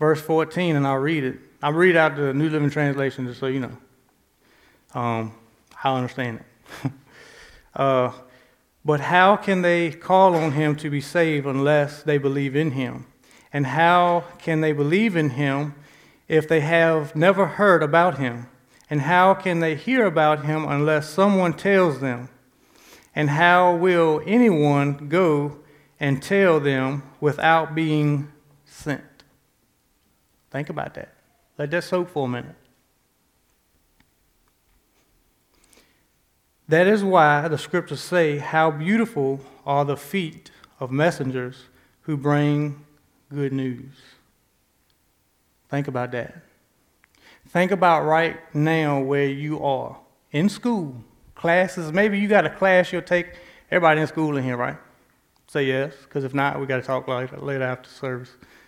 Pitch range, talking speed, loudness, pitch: 135-165 Hz, 140 wpm, -21 LUFS, 150 Hz